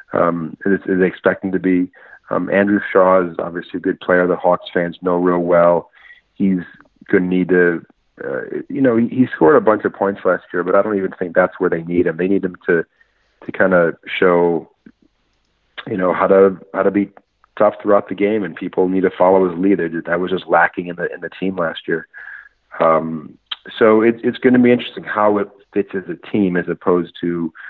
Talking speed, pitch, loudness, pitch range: 215 wpm, 95 Hz, -17 LUFS, 90-100 Hz